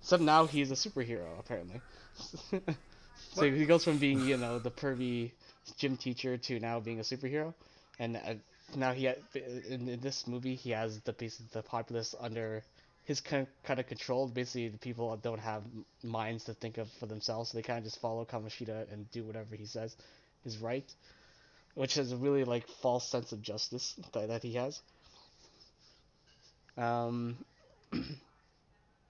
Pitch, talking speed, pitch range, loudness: 120 Hz, 170 wpm, 115-135 Hz, -36 LUFS